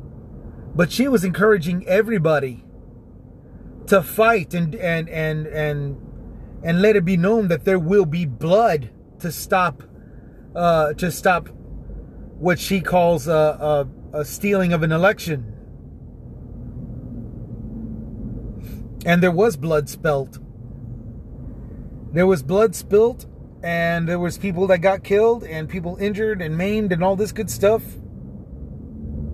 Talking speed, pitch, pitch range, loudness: 125 wpm, 160 Hz, 120-190 Hz, -20 LUFS